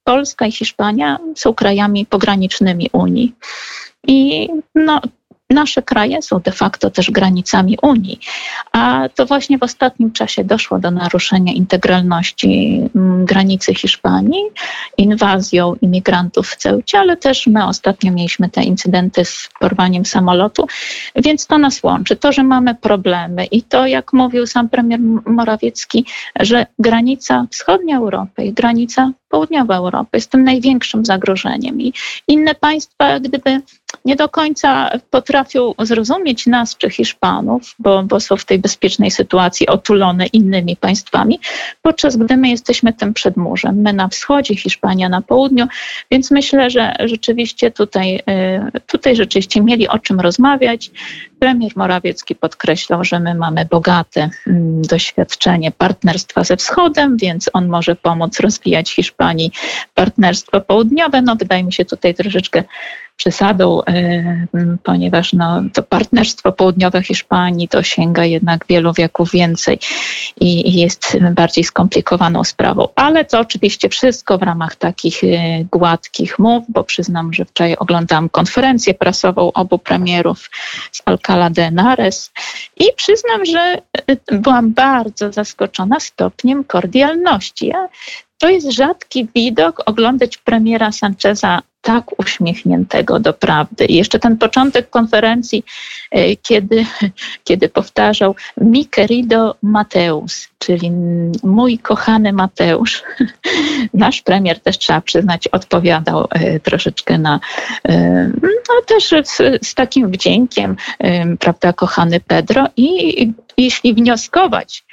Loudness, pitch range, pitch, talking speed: -13 LUFS, 180-255 Hz, 215 Hz, 125 wpm